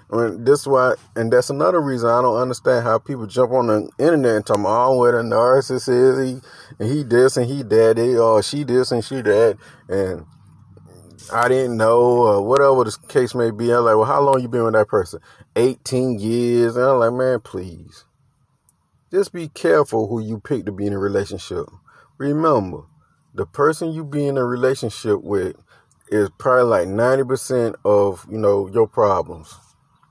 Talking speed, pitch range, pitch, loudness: 195 wpm, 110-135 Hz, 125 Hz, -18 LUFS